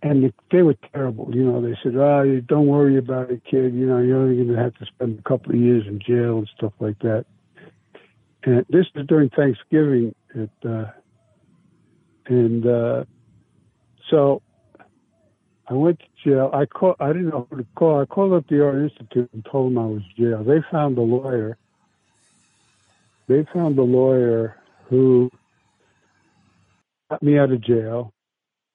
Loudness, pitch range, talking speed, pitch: -20 LUFS, 120-145 Hz, 175 wpm, 130 Hz